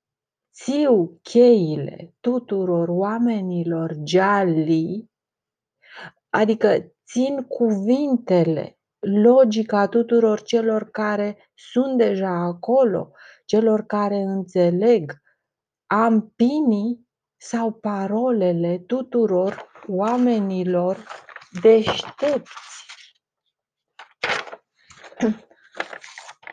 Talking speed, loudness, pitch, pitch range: 55 wpm, -20 LUFS, 215 Hz, 185-235 Hz